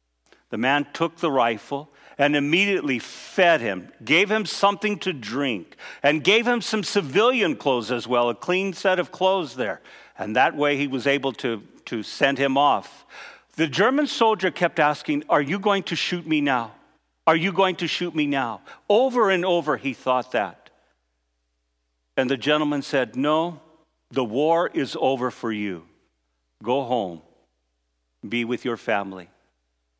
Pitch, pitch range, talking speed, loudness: 145 Hz, 115-175 Hz, 160 wpm, -23 LUFS